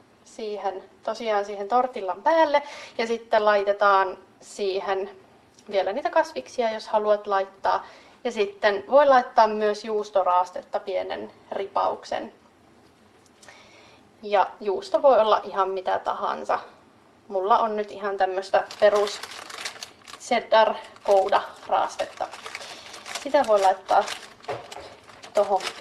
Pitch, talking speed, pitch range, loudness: 210 Hz, 100 wpm, 195-235 Hz, -24 LUFS